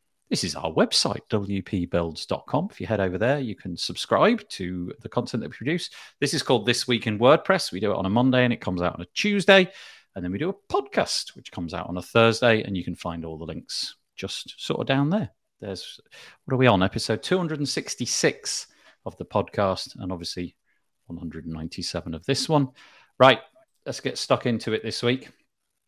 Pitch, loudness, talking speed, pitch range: 110 Hz, -24 LUFS, 200 wpm, 90-130 Hz